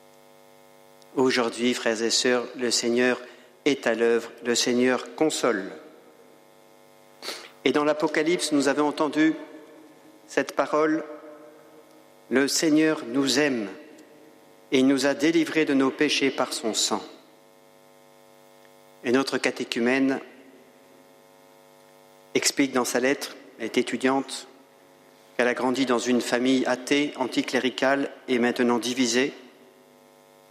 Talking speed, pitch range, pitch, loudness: 110 wpm, 110-140 Hz, 125 Hz, -24 LUFS